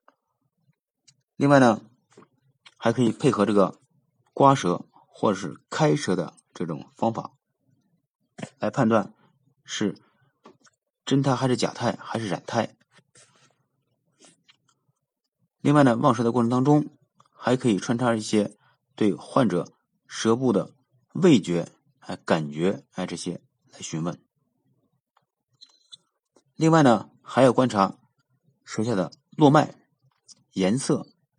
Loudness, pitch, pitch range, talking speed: -24 LUFS, 125 Hz, 115-140 Hz, 160 characters per minute